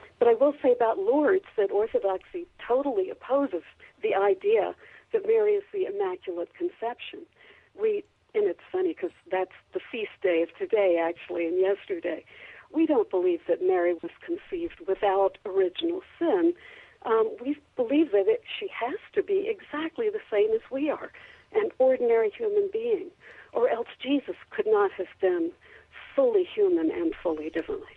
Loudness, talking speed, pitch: -27 LUFS, 155 wpm, 360 Hz